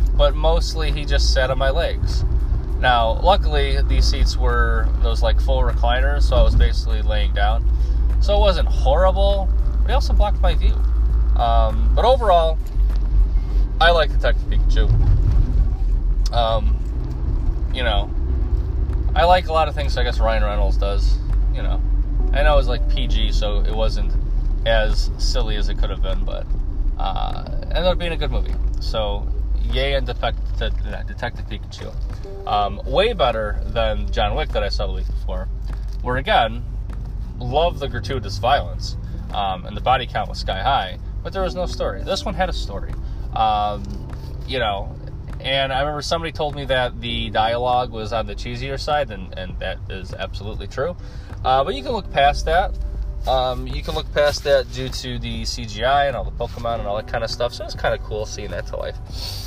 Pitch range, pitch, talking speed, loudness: 95-125 Hz, 105 Hz, 190 wpm, -21 LUFS